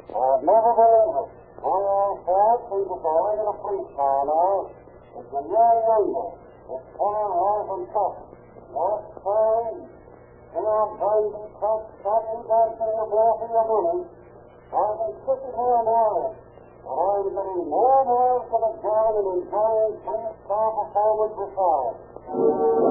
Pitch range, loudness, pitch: 195-225 Hz, -23 LUFS, 215 Hz